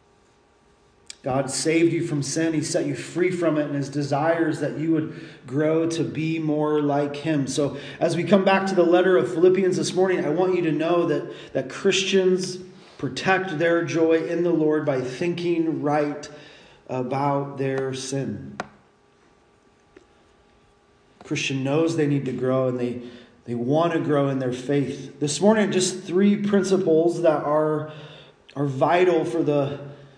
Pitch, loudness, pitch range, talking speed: 155 Hz, -23 LUFS, 140-170 Hz, 160 wpm